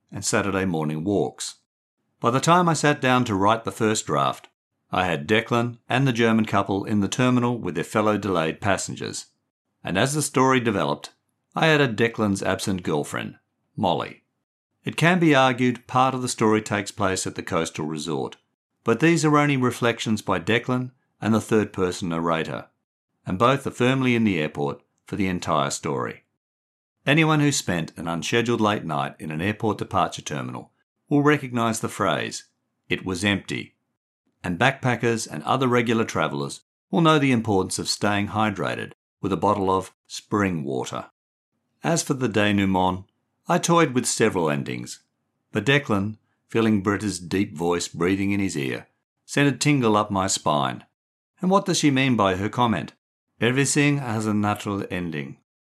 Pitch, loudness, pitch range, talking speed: 110 Hz, -23 LUFS, 95-125 Hz, 165 wpm